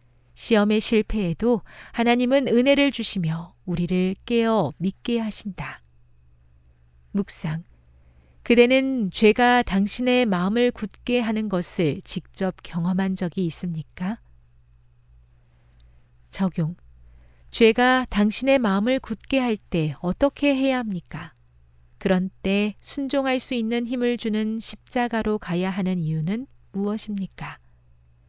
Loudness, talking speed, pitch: -23 LUFS, 230 characters per minute, 195 Hz